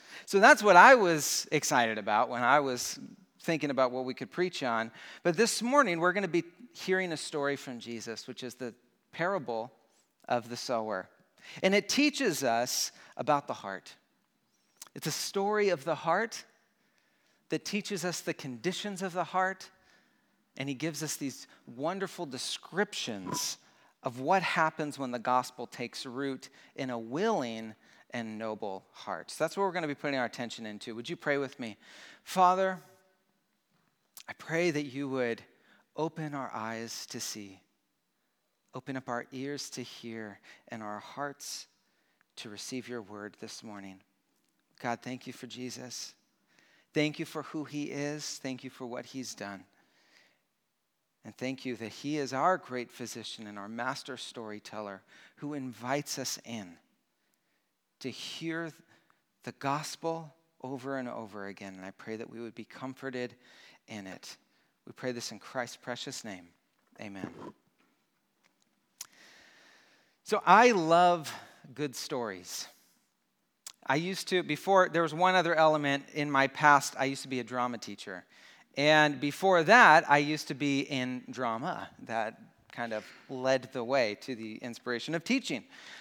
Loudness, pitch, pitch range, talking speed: -30 LUFS, 135 Hz, 120-165 Hz, 155 wpm